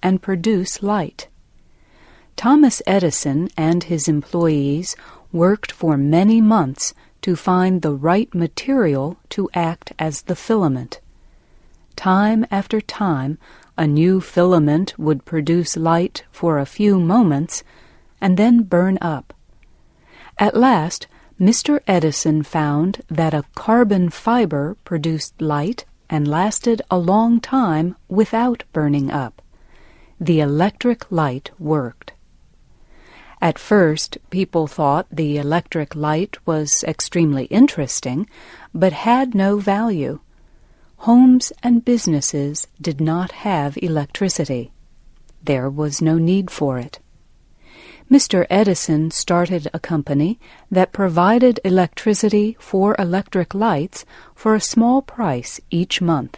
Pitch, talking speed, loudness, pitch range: 175 Hz, 115 wpm, -18 LUFS, 155-210 Hz